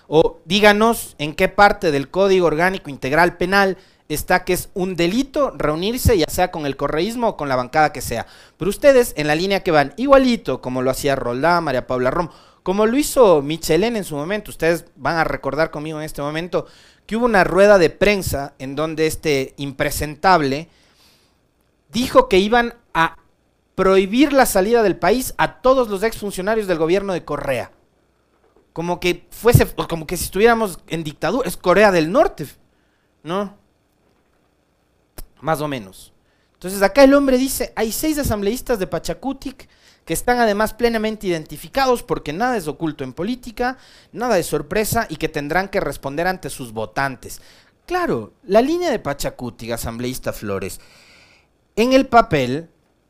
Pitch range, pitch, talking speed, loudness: 150-220 Hz, 175 Hz, 160 wpm, -18 LUFS